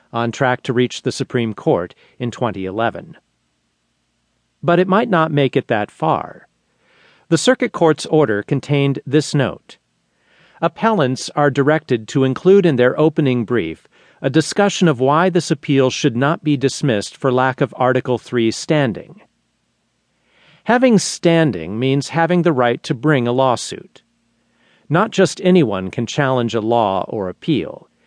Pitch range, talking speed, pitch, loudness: 120-160 Hz, 145 wpm, 135 Hz, -17 LUFS